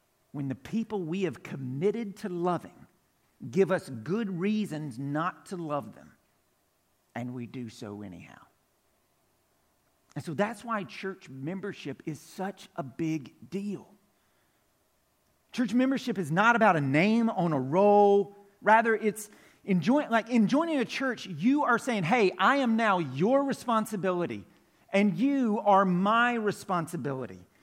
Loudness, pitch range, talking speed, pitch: -28 LUFS, 160-225 Hz, 140 wpm, 195 Hz